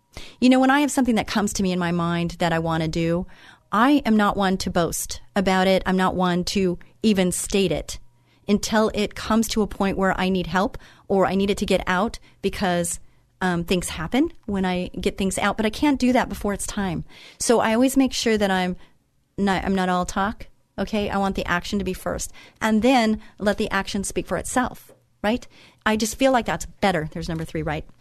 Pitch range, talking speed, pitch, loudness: 180-215 Hz, 225 wpm, 195 Hz, -22 LUFS